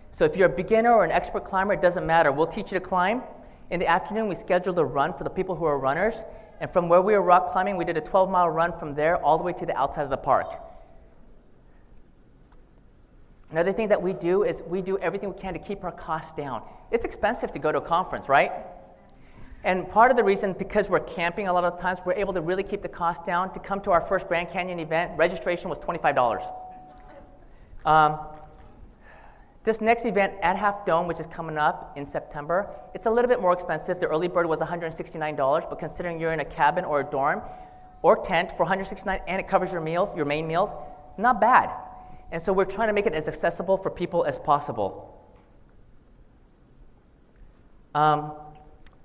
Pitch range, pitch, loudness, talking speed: 160-195 Hz, 180 Hz, -25 LUFS, 210 wpm